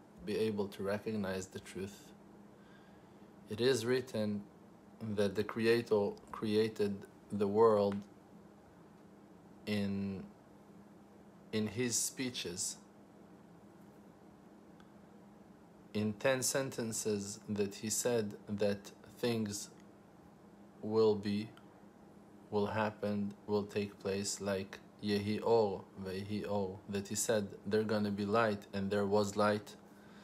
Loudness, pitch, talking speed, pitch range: -36 LUFS, 105 Hz, 100 wpm, 100-110 Hz